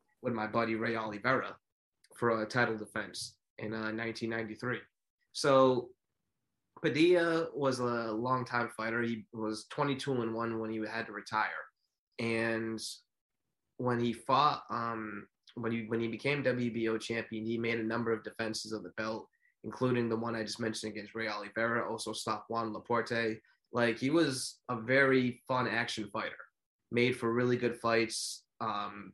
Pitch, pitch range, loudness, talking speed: 115 Hz, 110-120 Hz, -33 LUFS, 165 wpm